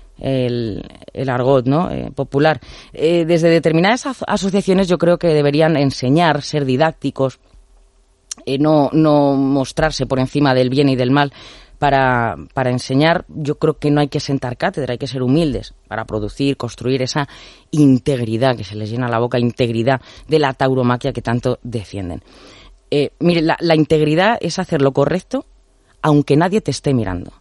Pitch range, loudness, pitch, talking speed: 125-155 Hz, -17 LUFS, 140 Hz, 170 wpm